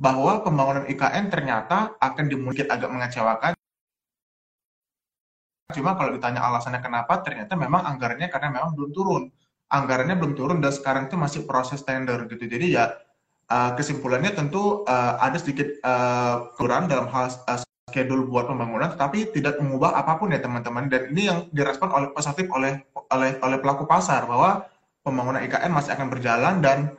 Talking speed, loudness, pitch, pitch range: 150 wpm, -24 LUFS, 135 Hz, 125-160 Hz